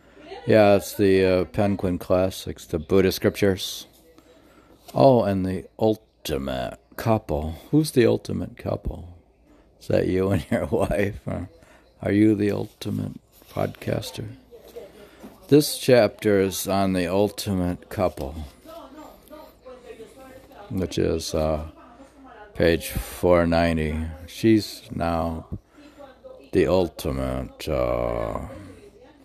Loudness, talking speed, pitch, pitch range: -23 LUFS, 95 wpm, 100 Hz, 85-110 Hz